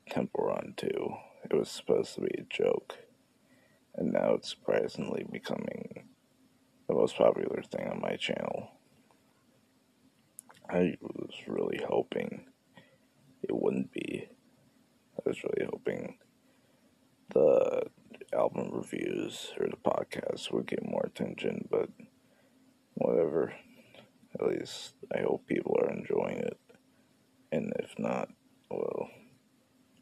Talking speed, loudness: 115 wpm, -33 LUFS